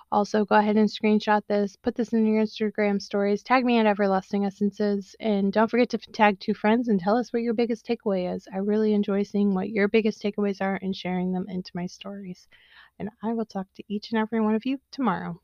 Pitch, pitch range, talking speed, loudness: 210 Hz, 200-220 Hz, 230 wpm, -25 LUFS